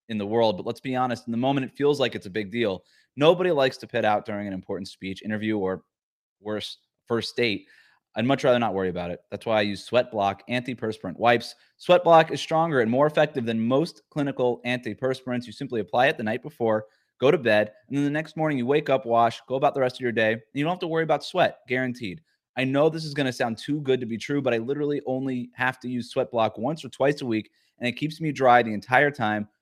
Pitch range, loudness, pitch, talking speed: 110-140 Hz, -25 LUFS, 125 Hz, 255 wpm